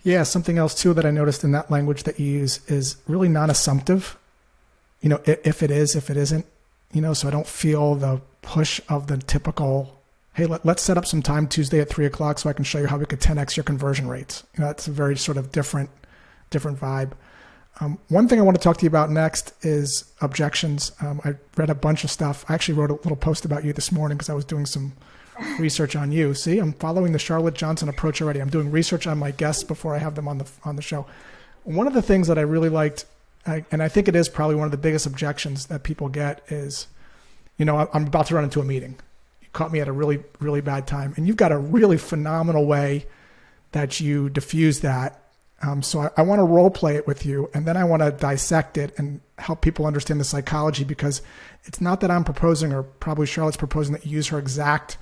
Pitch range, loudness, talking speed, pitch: 145-160 Hz, -22 LUFS, 240 wpm, 150 Hz